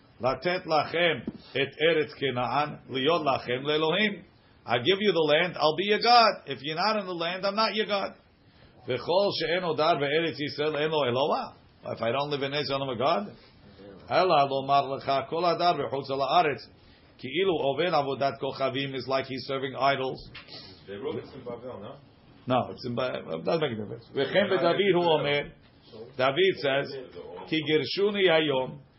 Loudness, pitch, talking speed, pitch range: -27 LUFS, 145 Hz, 95 wpm, 135-170 Hz